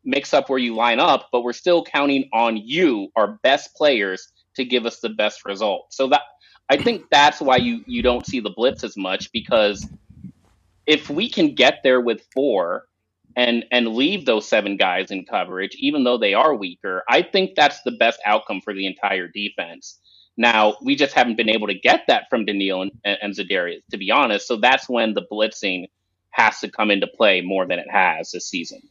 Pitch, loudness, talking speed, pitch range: 120 Hz, -19 LUFS, 205 wpm, 105-140 Hz